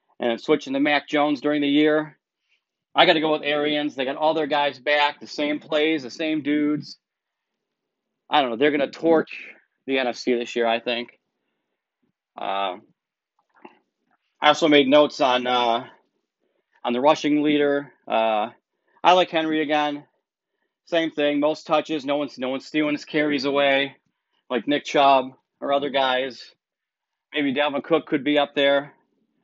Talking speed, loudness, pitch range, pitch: 160 wpm, -22 LUFS, 135-150 Hz, 145 Hz